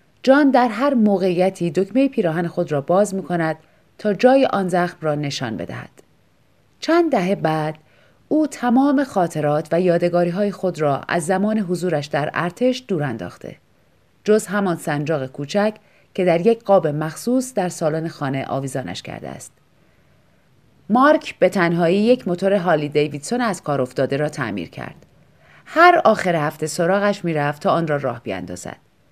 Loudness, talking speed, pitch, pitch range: -19 LUFS, 155 wpm, 180 Hz, 155-215 Hz